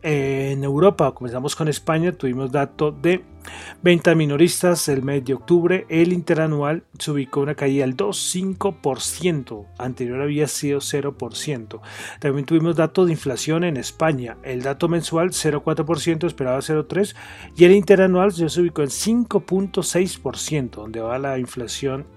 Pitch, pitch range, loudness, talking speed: 150 Hz, 135-175 Hz, -20 LUFS, 135 wpm